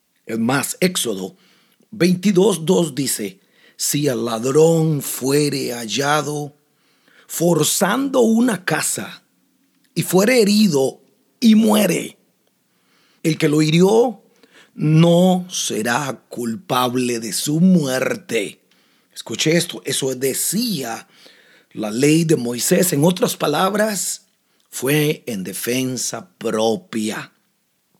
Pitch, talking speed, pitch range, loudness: 160 Hz, 90 wpm, 135-195 Hz, -18 LUFS